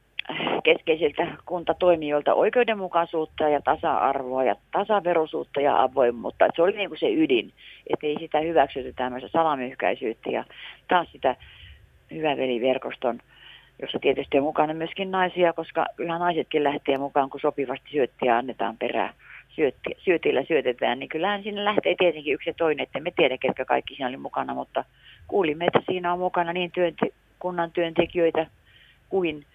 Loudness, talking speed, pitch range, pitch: -25 LUFS, 140 wpm, 145-180 Hz, 165 Hz